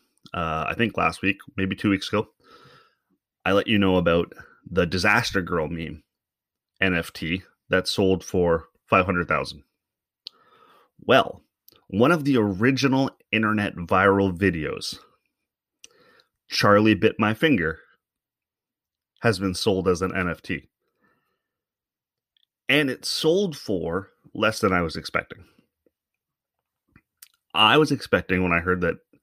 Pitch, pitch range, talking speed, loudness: 100 Hz, 90-110 Hz, 120 wpm, -23 LUFS